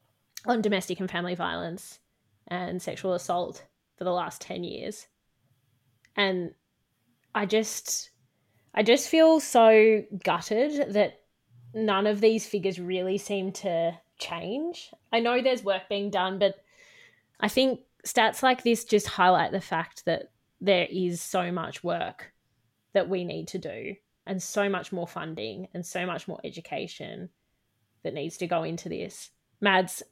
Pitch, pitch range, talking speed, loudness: 190 Hz, 175-220 Hz, 145 wpm, -27 LUFS